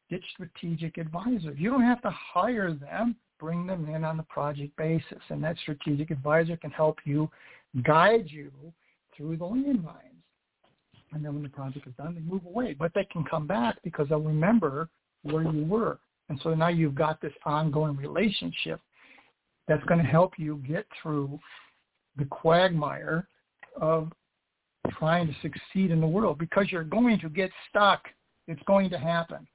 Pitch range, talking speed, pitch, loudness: 155-185 Hz, 170 wpm, 165 Hz, -28 LUFS